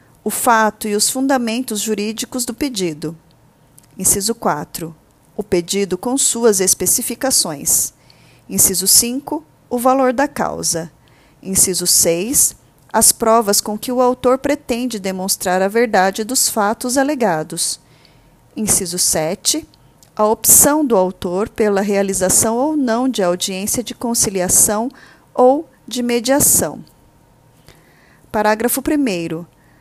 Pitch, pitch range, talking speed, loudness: 215 Hz, 180-250 Hz, 110 wpm, -15 LUFS